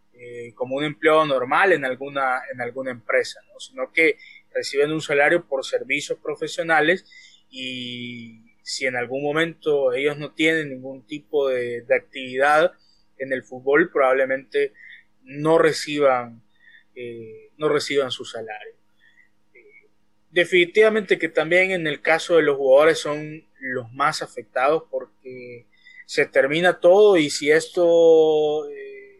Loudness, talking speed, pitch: -20 LUFS, 130 wpm, 155 Hz